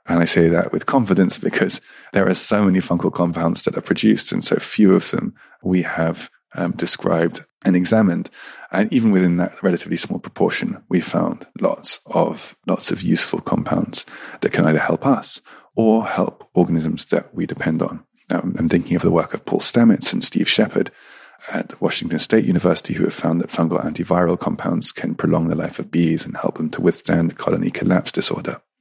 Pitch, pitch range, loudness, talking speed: 85 Hz, 85-90 Hz, -19 LUFS, 190 wpm